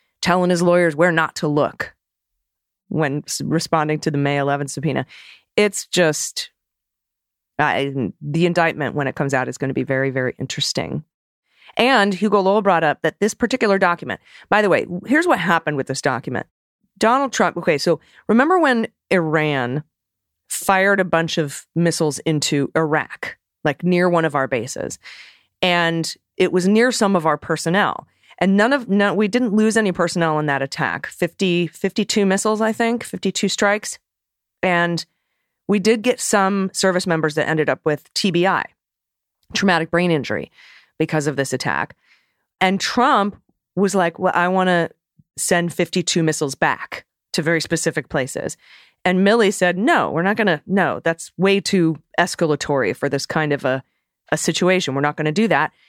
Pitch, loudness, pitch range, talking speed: 170 Hz, -19 LUFS, 155-195 Hz, 165 wpm